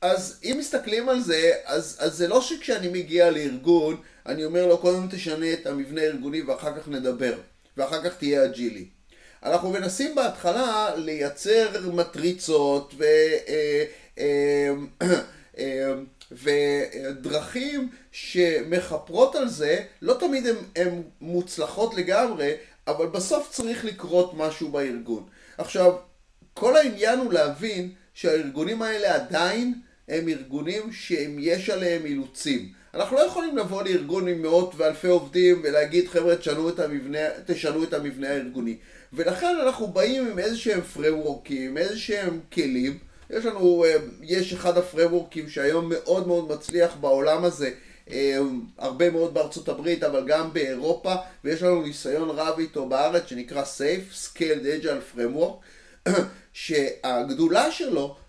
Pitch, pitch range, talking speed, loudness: 175 Hz, 150-215 Hz, 125 wpm, -25 LUFS